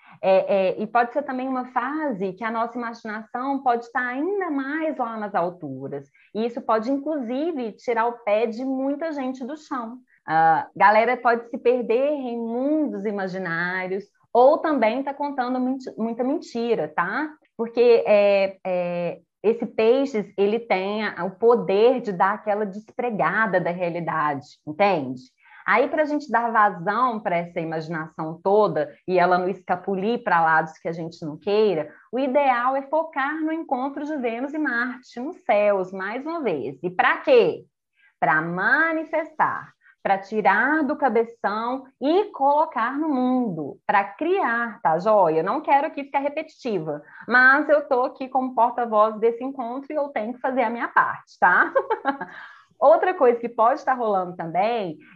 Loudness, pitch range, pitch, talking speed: -22 LUFS, 195-275 Hz, 235 Hz, 160 wpm